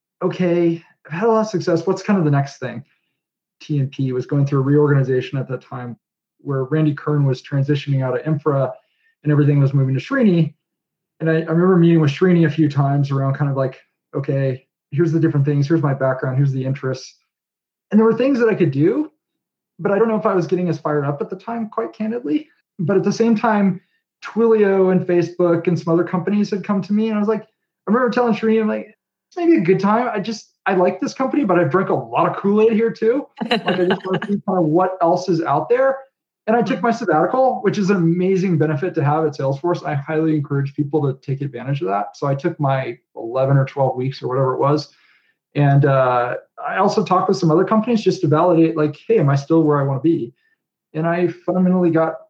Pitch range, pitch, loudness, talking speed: 145-205 Hz, 170 Hz, -18 LUFS, 235 wpm